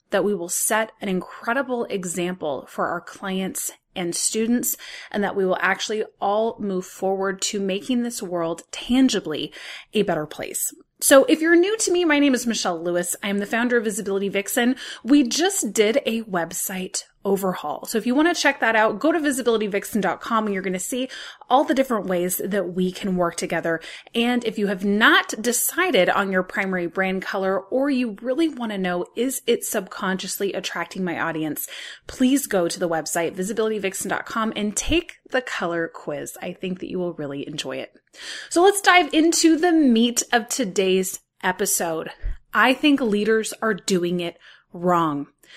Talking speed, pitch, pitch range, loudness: 180 wpm, 210 Hz, 185-255 Hz, -22 LUFS